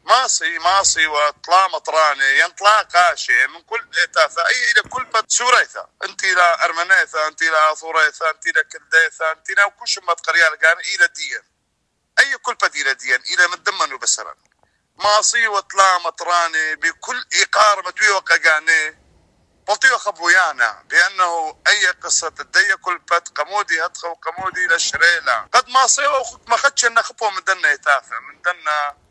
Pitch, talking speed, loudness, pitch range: 190 Hz, 145 wpm, -16 LUFS, 165-220 Hz